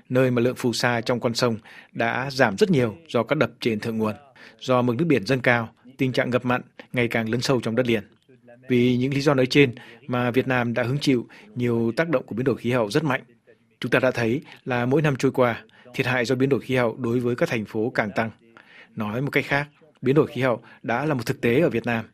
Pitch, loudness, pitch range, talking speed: 125 Hz, -23 LUFS, 115-135 Hz, 260 wpm